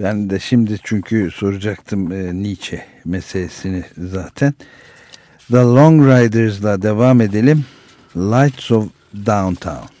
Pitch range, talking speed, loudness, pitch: 95-120 Hz, 100 wpm, -15 LUFS, 105 Hz